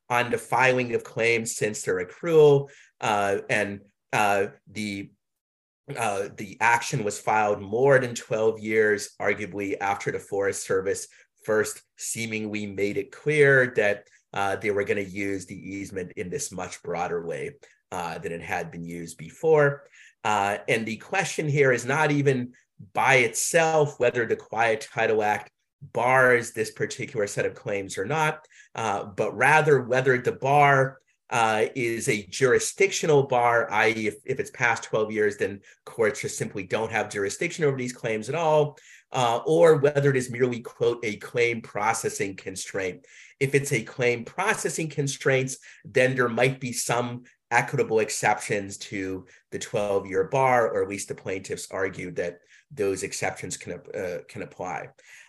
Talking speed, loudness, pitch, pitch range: 160 wpm, -25 LUFS, 125 Hz, 110-150 Hz